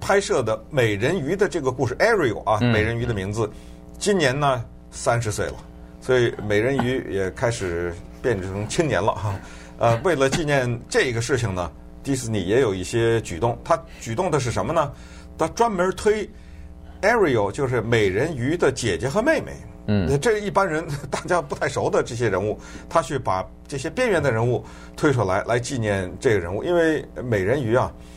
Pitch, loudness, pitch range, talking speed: 115 Hz, -22 LUFS, 85-140 Hz, 285 characters per minute